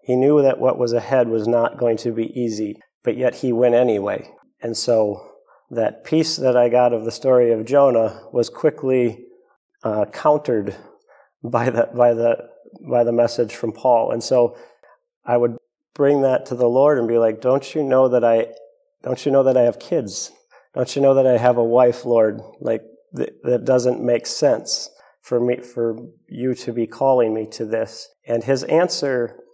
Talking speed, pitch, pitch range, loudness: 190 wpm, 120 Hz, 115-130 Hz, -19 LUFS